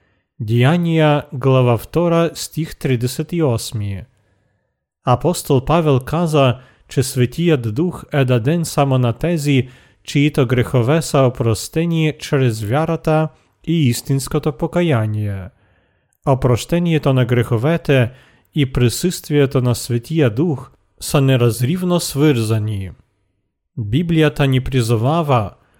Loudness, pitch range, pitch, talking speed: -17 LUFS, 120-155 Hz, 135 Hz, 100 wpm